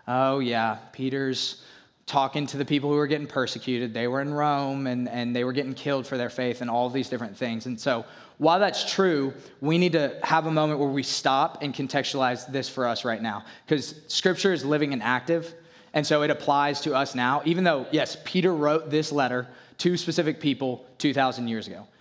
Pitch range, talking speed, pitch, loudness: 125-150 Hz, 205 wpm, 135 Hz, -26 LUFS